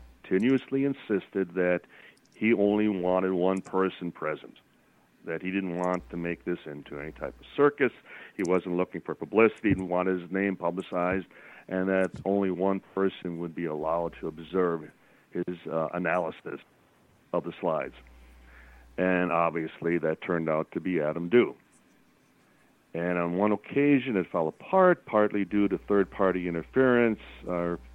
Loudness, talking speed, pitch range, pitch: -28 LUFS, 150 wpm, 85-100 Hz, 90 Hz